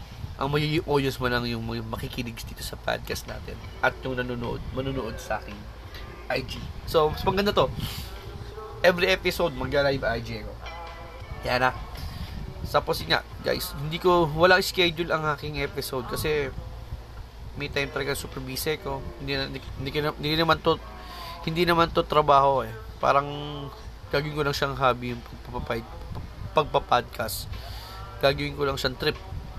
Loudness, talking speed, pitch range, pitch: -26 LUFS, 155 wpm, 115-150 Hz, 135 Hz